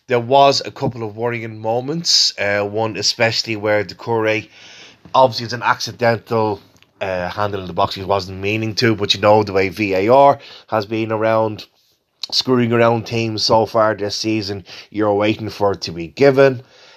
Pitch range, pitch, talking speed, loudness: 100-115 Hz, 110 Hz, 175 wpm, -17 LUFS